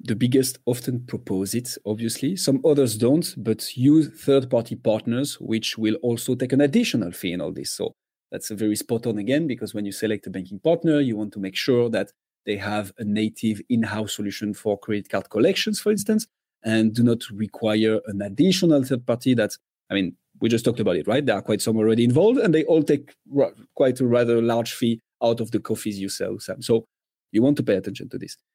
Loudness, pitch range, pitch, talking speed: -23 LUFS, 110-130 Hz, 115 Hz, 215 wpm